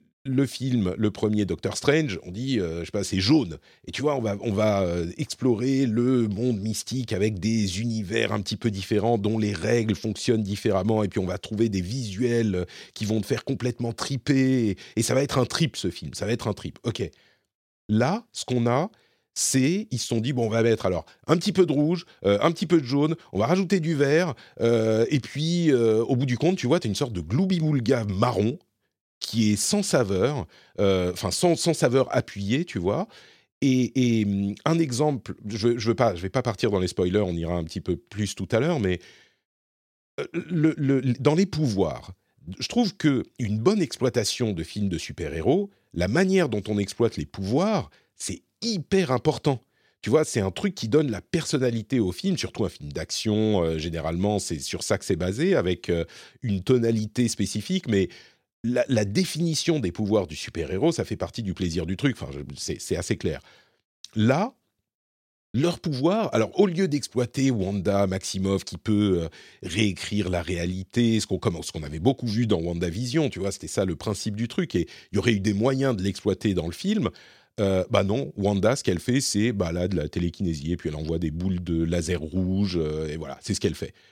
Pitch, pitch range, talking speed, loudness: 110 Hz, 95-135 Hz, 210 wpm, -25 LUFS